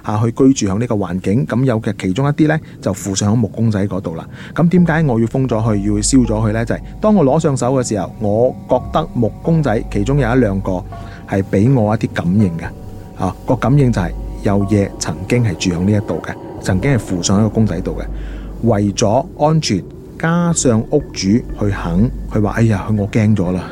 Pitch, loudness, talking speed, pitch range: 110 Hz, -16 LUFS, 300 characters per minute, 100-130 Hz